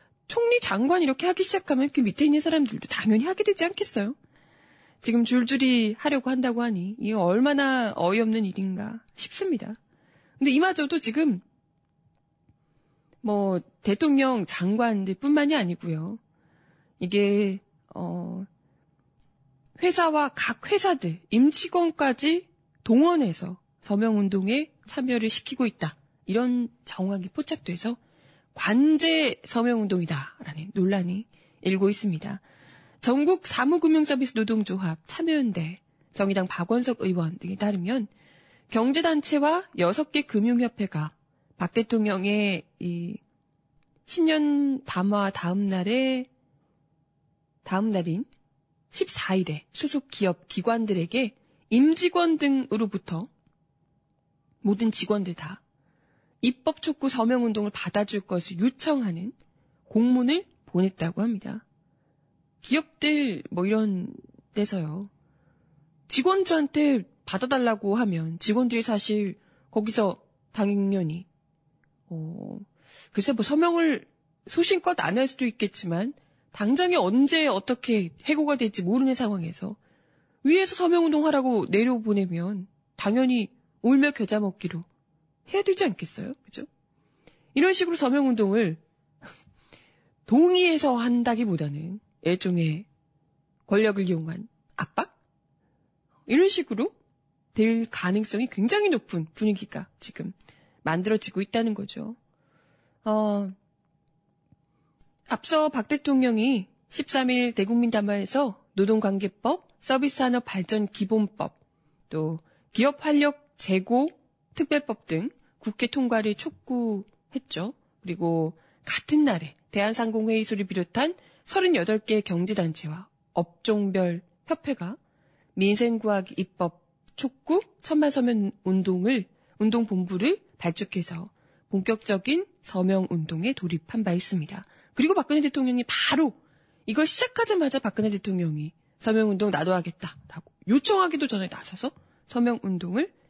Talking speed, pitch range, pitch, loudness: 250 characters per minute, 180-265 Hz, 215 Hz, -26 LUFS